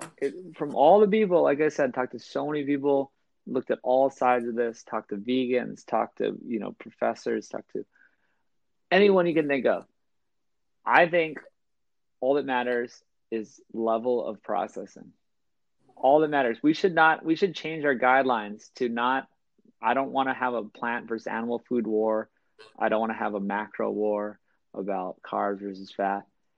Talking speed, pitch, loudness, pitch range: 180 wpm, 125 Hz, -26 LUFS, 115-150 Hz